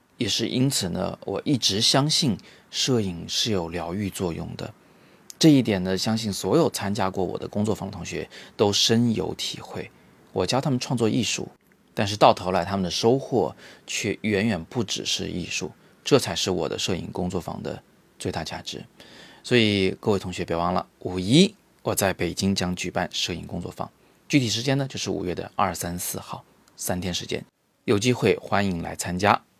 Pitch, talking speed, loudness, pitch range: 100 Hz, 270 characters per minute, -24 LUFS, 90-115 Hz